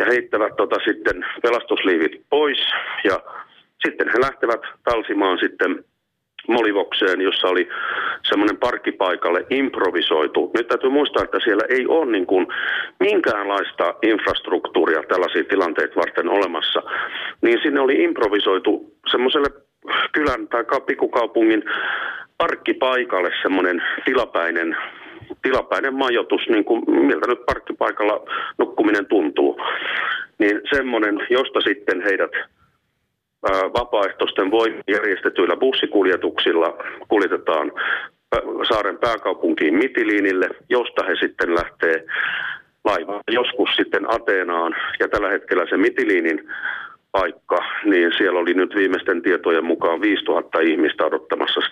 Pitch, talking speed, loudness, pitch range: 390 Hz, 100 wpm, -20 LUFS, 360-445 Hz